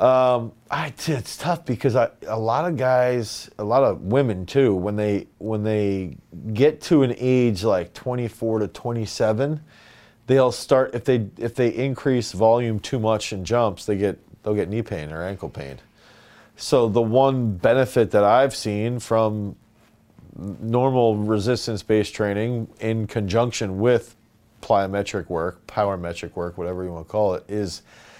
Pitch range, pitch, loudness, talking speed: 105-125 Hz, 110 Hz, -22 LUFS, 160 wpm